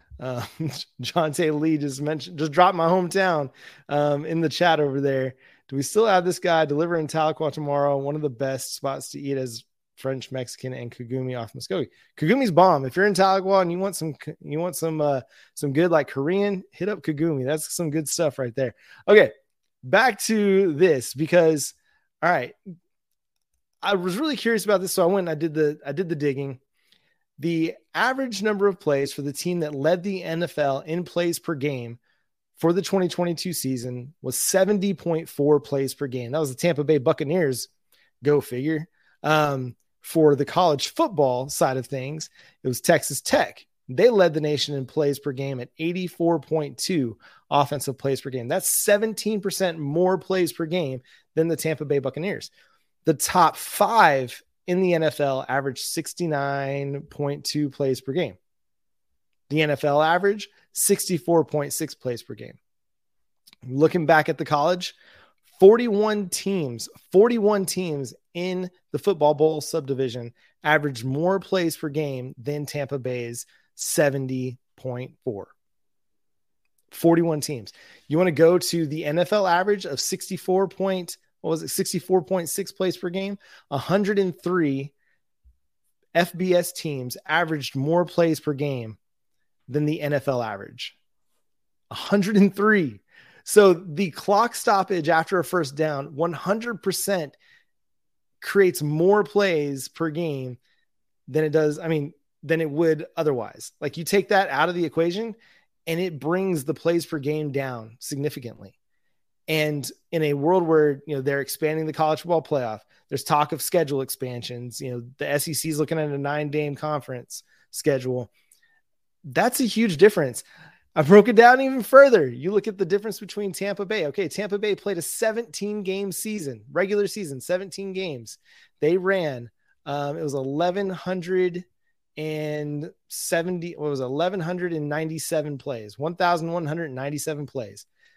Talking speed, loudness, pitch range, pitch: 150 wpm, -23 LUFS, 140-185 Hz, 160 Hz